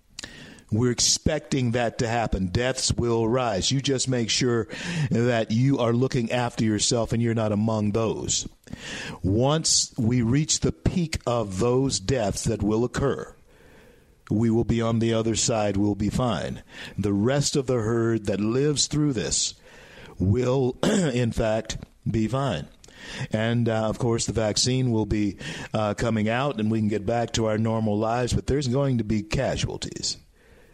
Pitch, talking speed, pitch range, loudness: 115 Hz, 165 wpm, 110-130 Hz, -24 LUFS